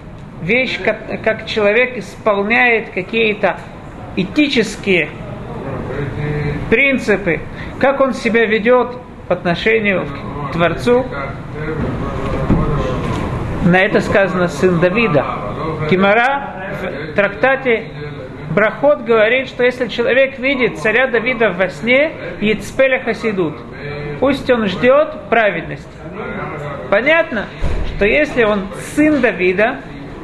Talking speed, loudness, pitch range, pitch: 90 wpm, -15 LUFS, 165-245 Hz, 210 Hz